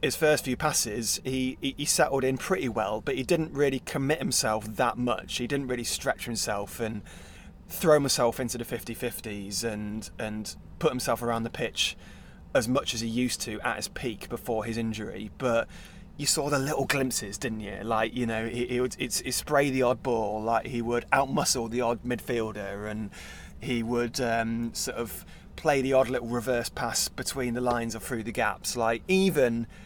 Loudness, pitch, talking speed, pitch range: -28 LUFS, 120 Hz, 195 wpm, 110-130 Hz